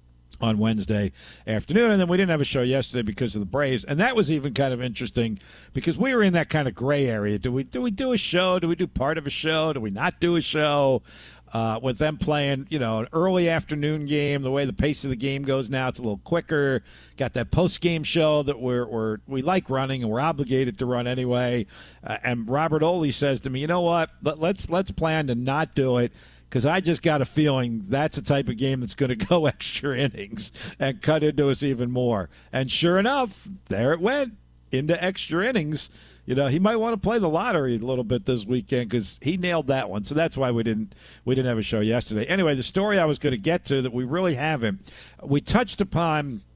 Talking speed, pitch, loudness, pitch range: 240 wpm, 140 Hz, -24 LUFS, 125-165 Hz